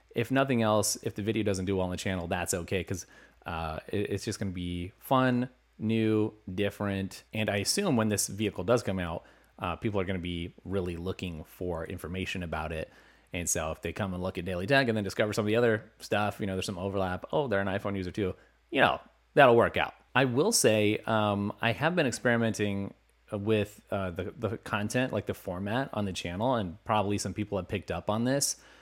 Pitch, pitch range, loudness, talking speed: 100 Hz, 95-110 Hz, -30 LUFS, 225 wpm